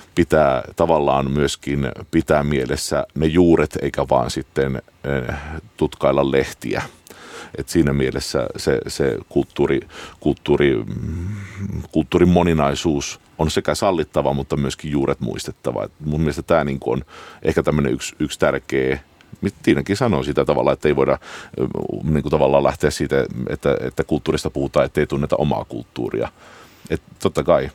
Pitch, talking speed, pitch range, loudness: 75 Hz, 135 wpm, 70-80 Hz, -20 LUFS